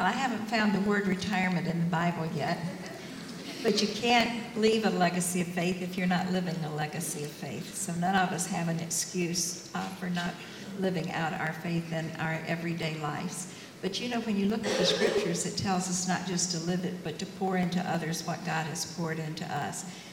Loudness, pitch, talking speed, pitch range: -30 LUFS, 180 Hz, 215 wpm, 165-190 Hz